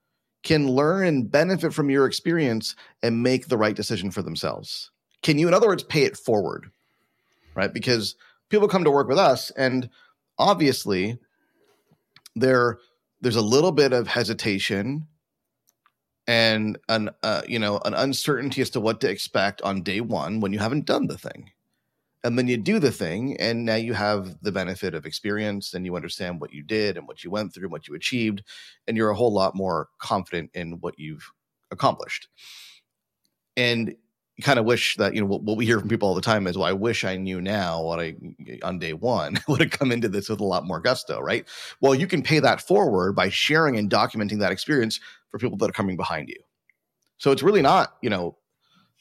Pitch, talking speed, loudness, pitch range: 115 Hz, 200 wpm, -23 LUFS, 100-130 Hz